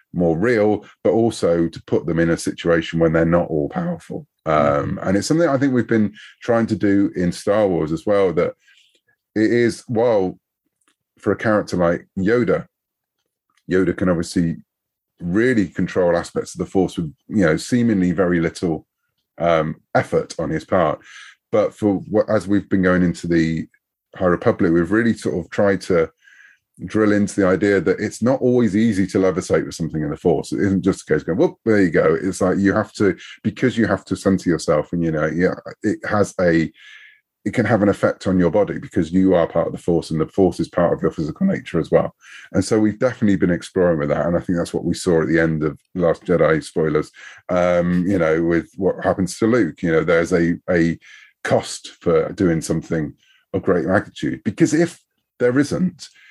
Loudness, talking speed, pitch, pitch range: -19 LUFS, 210 wpm, 95 Hz, 85-105 Hz